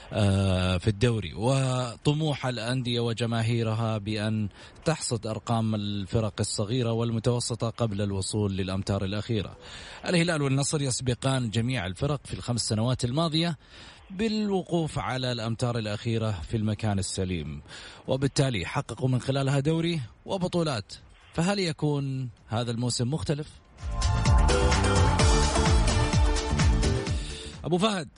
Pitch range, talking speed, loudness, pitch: 100-135 Hz, 95 wpm, -27 LUFS, 115 Hz